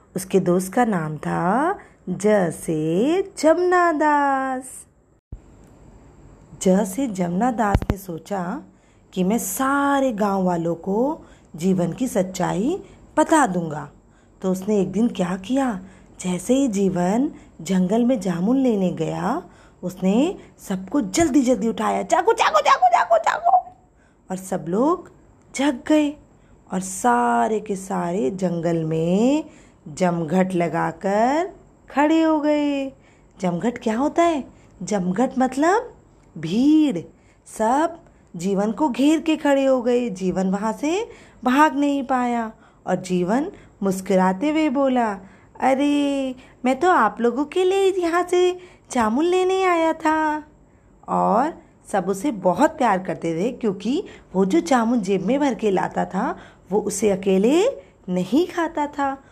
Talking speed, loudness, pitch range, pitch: 125 wpm, -21 LUFS, 190-295 Hz, 240 Hz